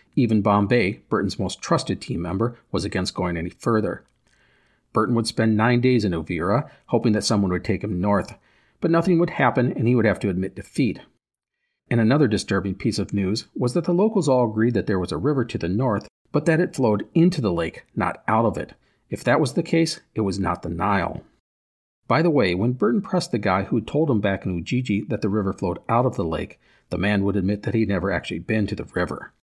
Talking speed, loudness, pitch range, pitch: 230 wpm, -22 LUFS, 95-125 Hz, 105 Hz